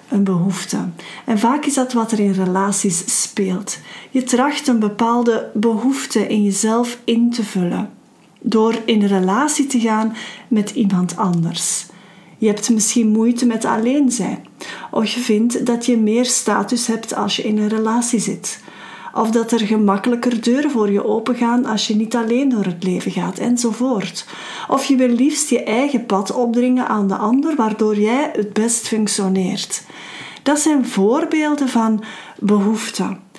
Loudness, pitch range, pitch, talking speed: -17 LUFS, 210-245 Hz, 225 Hz, 160 wpm